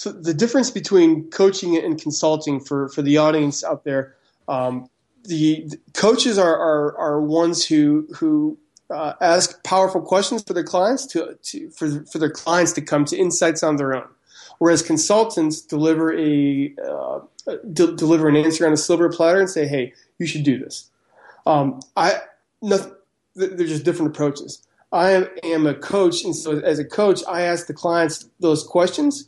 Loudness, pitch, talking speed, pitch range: -19 LUFS, 165 Hz, 175 wpm, 150-190 Hz